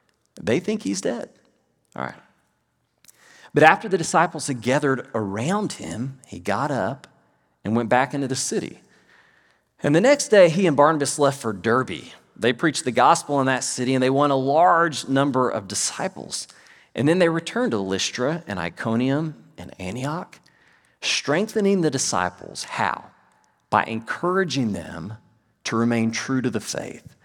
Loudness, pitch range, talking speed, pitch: -22 LUFS, 110-160 Hz, 155 wpm, 130 Hz